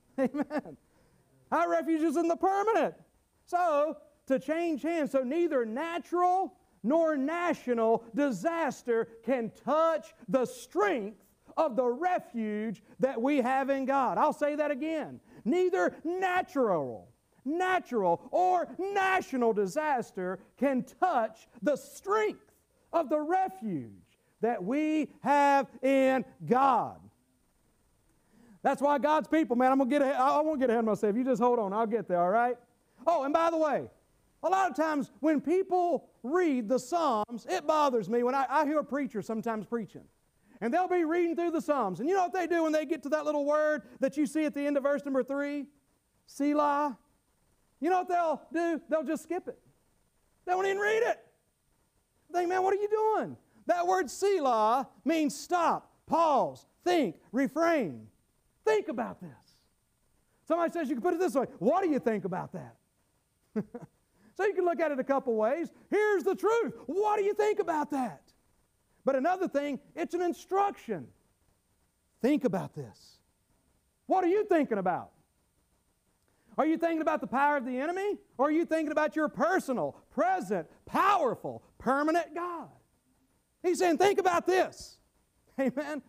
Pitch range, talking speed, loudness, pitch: 255-345 Hz, 160 wpm, -30 LUFS, 295 Hz